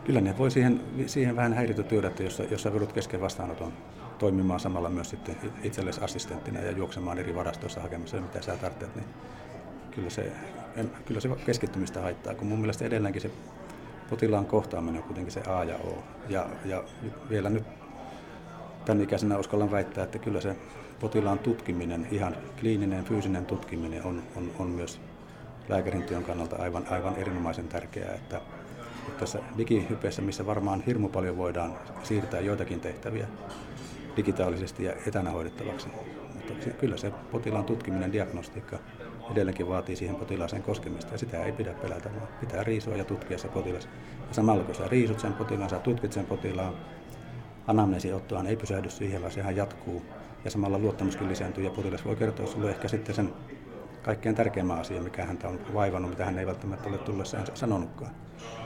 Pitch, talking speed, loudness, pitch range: 100 Hz, 165 wpm, -32 LUFS, 90-110 Hz